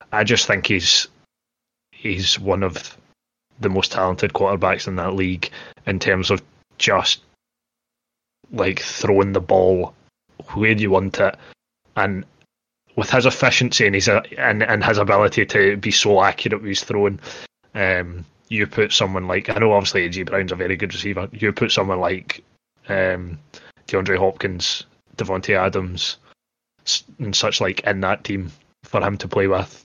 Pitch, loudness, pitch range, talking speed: 95 Hz, -19 LUFS, 95-105 Hz, 155 wpm